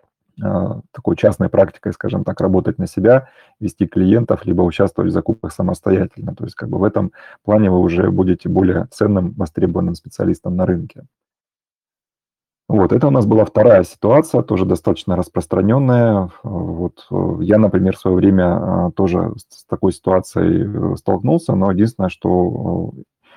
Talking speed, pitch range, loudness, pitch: 140 wpm, 90-110 Hz, -16 LUFS, 95 Hz